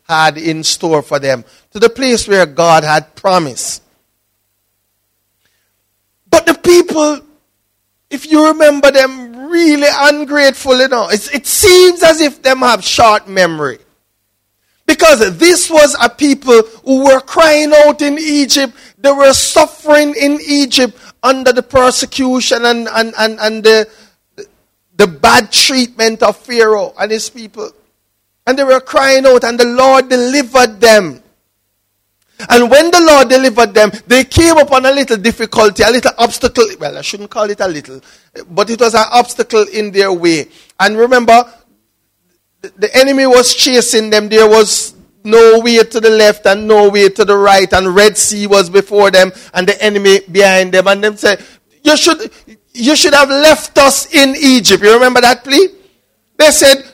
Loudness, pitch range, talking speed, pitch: -9 LUFS, 200-275 Hz, 160 wpm, 235 Hz